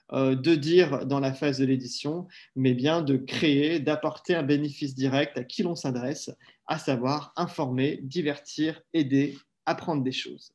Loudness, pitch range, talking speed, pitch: -27 LUFS, 135-160 Hz, 155 wpm, 145 Hz